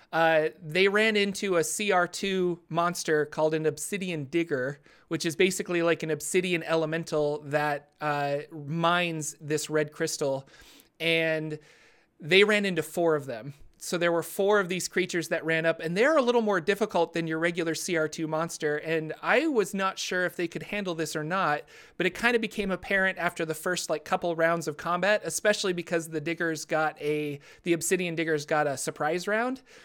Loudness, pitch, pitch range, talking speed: -27 LUFS, 165 Hz, 155-185 Hz, 185 wpm